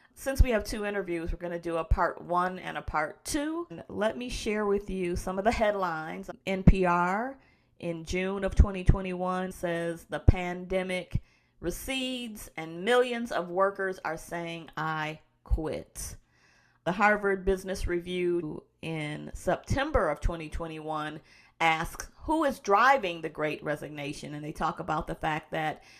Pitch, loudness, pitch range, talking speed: 180 Hz, -30 LUFS, 165-200 Hz, 150 wpm